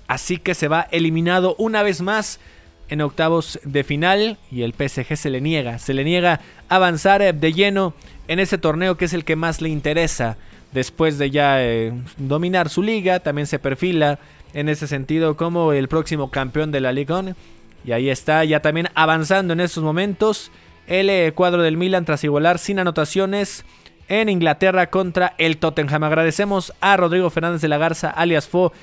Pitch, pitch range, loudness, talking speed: 160 Hz, 145-180 Hz, -19 LUFS, 180 wpm